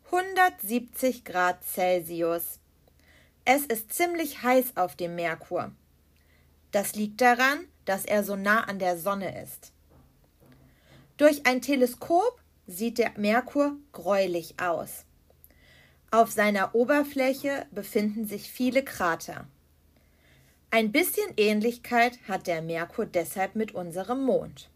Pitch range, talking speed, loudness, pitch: 165-245 Hz, 110 wpm, -27 LUFS, 200 Hz